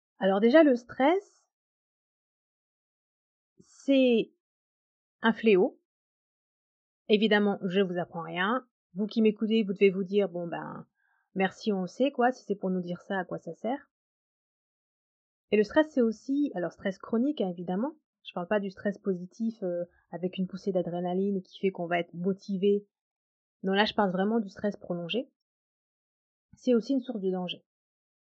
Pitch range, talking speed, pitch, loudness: 185-240 Hz, 165 wpm, 205 Hz, -29 LUFS